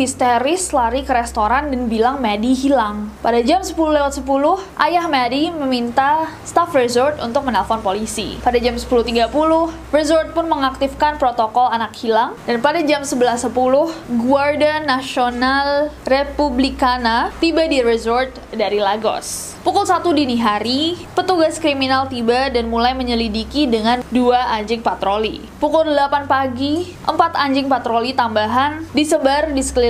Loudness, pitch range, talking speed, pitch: -17 LUFS, 235-295 Hz, 130 wpm, 265 Hz